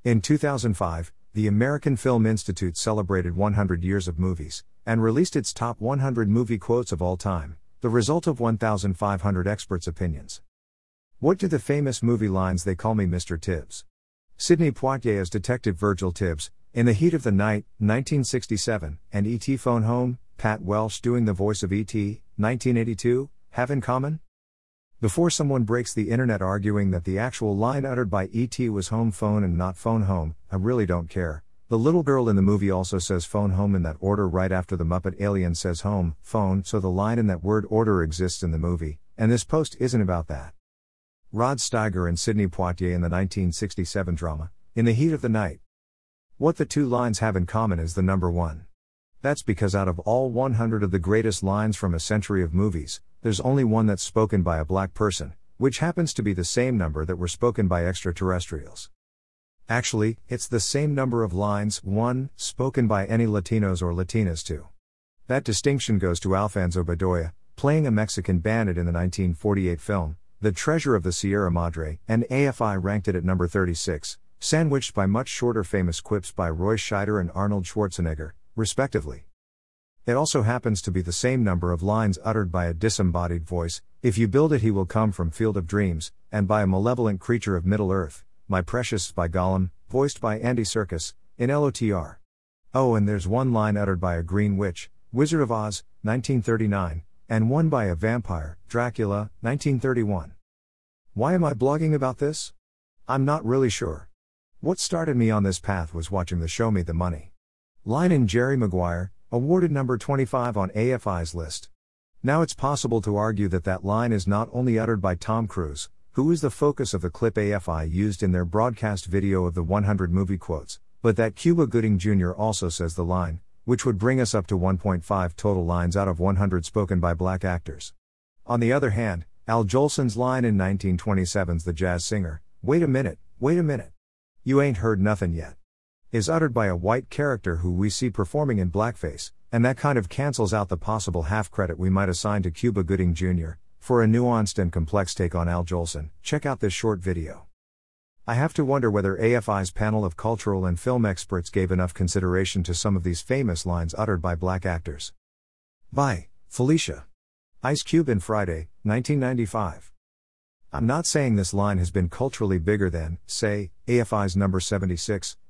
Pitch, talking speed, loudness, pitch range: 100 Hz, 185 wpm, -25 LUFS, 90-115 Hz